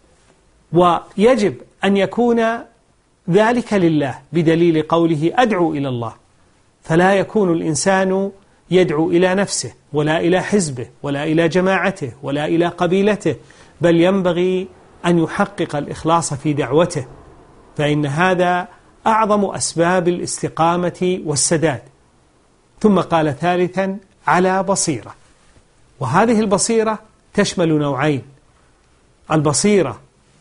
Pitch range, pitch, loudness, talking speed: 150-190 Hz, 170 Hz, -17 LUFS, 95 wpm